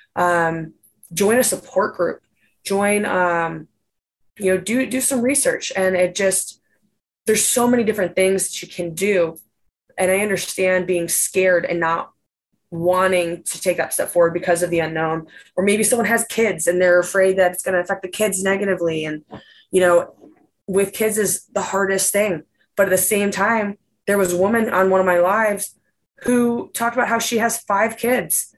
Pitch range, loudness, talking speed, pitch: 180-220 Hz, -19 LUFS, 185 wpm, 190 Hz